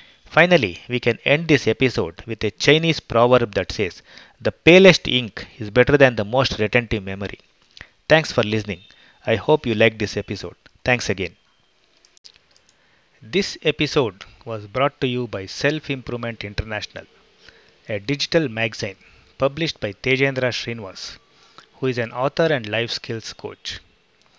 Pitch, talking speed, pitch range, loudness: 120 Hz, 145 wpm, 110-140 Hz, -20 LUFS